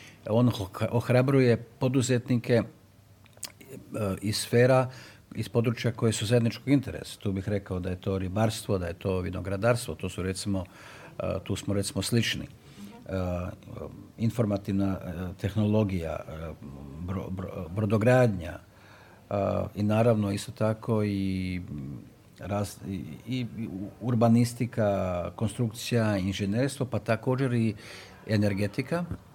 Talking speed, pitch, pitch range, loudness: 90 wpm, 105 Hz, 95-120 Hz, -28 LUFS